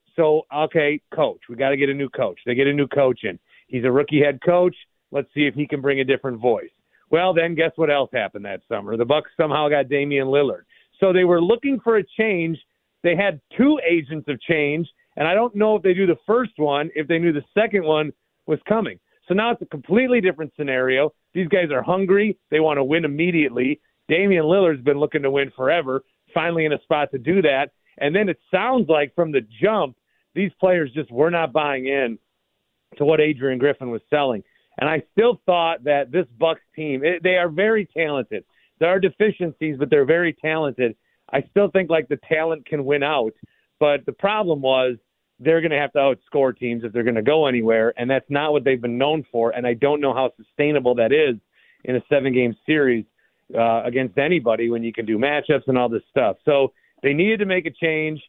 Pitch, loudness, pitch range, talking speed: 150 Hz, -20 LUFS, 135-175 Hz, 215 wpm